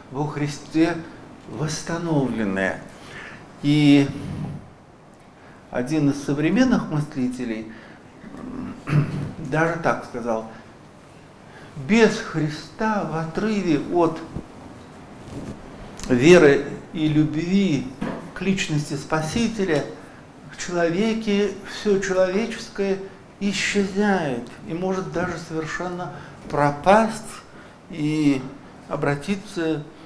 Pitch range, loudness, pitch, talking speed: 145-195 Hz, -22 LUFS, 160 Hz, 70 wpm